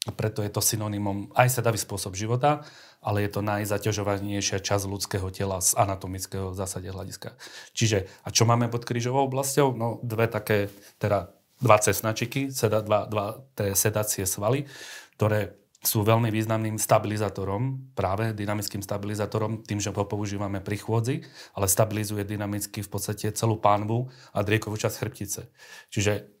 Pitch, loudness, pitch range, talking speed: 105 Hz, -26 LUFS, 100-115 Hz, 145 wpm